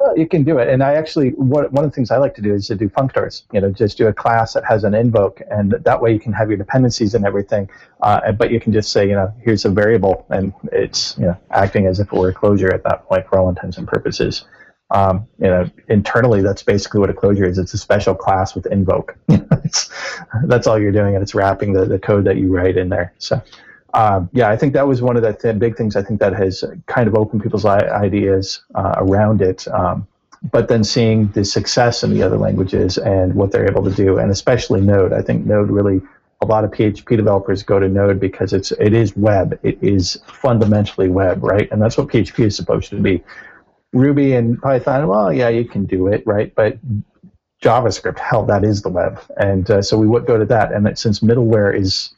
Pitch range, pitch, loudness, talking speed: 95-115 Hz, 105 Hz, -16 LUFS, 235 wpm